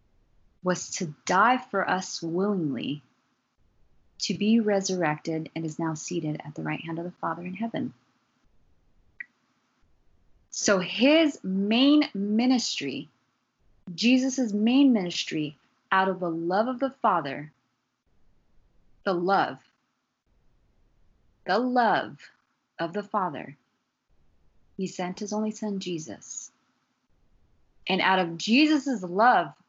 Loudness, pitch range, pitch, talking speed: -26 LUFS, 160-220 Hz, 185 Hz, 110 wpm